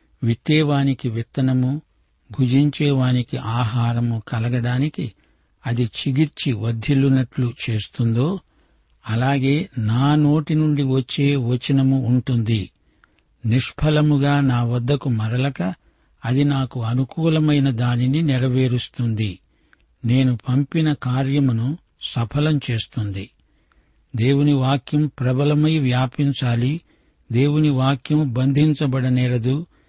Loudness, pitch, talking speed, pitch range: -20 LUFS, 130 Hz, 75 wpm, 120-145 Hz